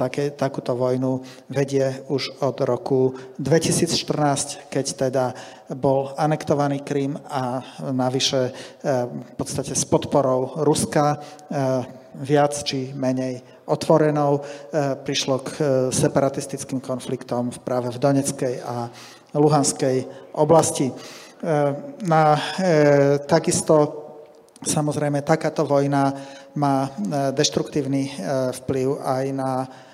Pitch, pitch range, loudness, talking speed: 140 Hz, 130-150 Hz, -22 LUFS, 85 wpm